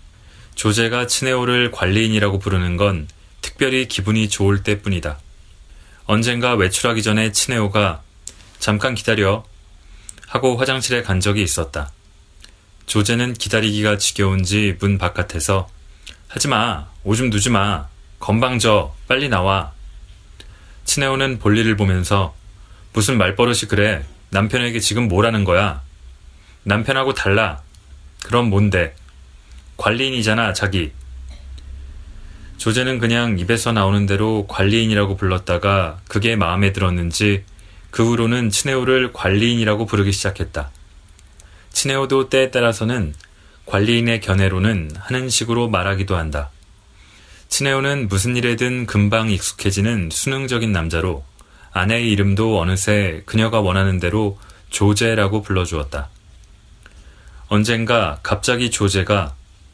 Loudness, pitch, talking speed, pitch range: -18 LUFS, 100 Hz, 280 characters per minute, 90-115 Hz